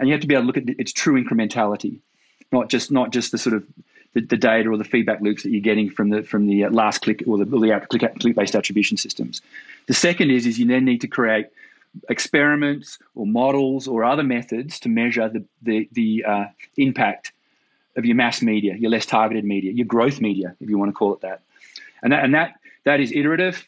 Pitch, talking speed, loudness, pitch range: 120 Hz, 230 wpm, -20 LUFS, 110-140 Hz